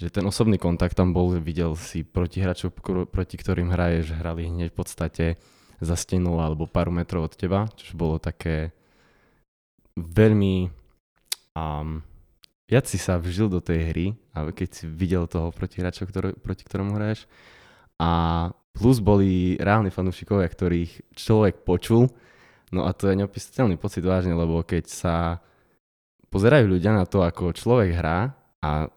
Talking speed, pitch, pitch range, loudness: 150 wpm, 90 Hz, 85-100 Hz, -24 LUFS